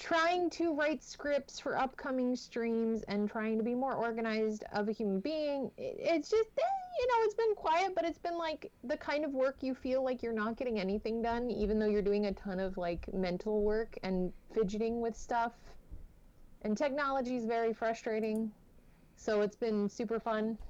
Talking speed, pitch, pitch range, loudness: 185 wpm, 230 Hz, 215-295 Hz, -35 LUFS